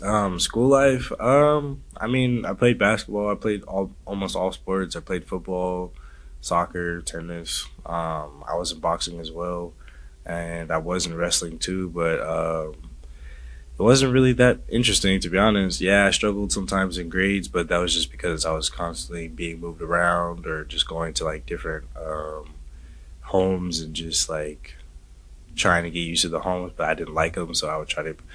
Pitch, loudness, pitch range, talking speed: 85 Hz, -23 LUFS, 80-95 Hz, 185 wpm